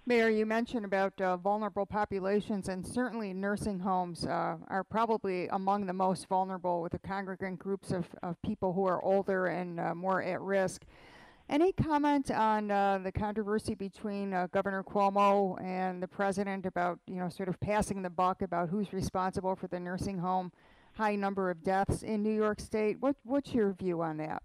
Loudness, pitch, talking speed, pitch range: -33 LUFS, 195 Hz, 185 wpm, 185-210 Hz